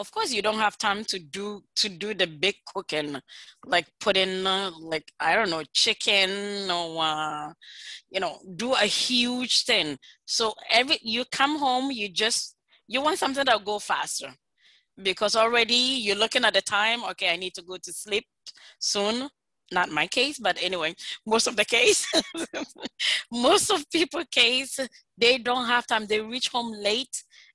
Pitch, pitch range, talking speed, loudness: 215 Hz, 190-250 Hz, 170 wpm, -24 LUFS